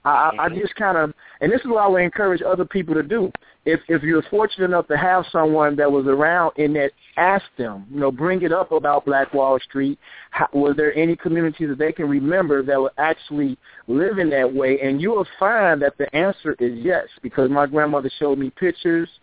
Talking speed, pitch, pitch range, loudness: 220 wpm, 155 Hz, 140-175 Hz, -20 LUFS